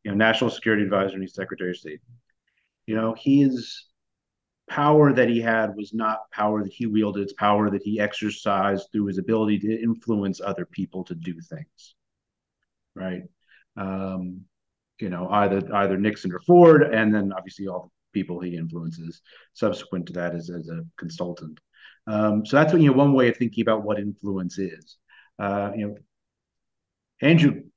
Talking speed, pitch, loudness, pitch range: 175 wpm, 105 Hz, -23 LUFS, 95-110 Hz